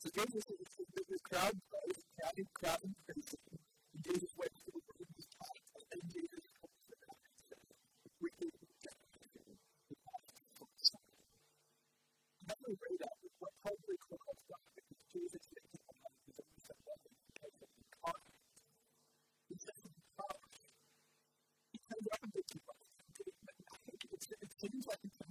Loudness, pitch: -46 LUFS, 230 Hz